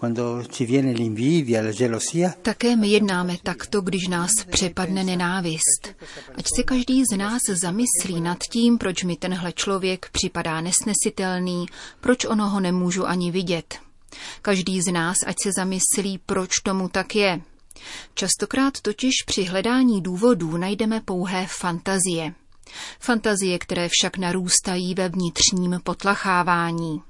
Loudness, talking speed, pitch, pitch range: -22 LUFS, 115 wpm, 185 Hz, 175-205 Hz